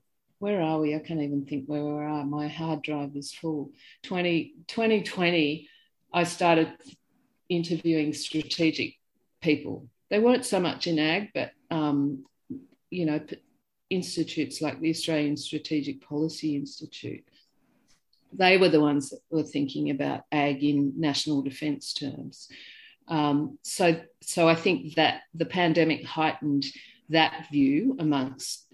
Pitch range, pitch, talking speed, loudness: 145-170 Hz, 155 Hz, 130 wpm, -27 LUFS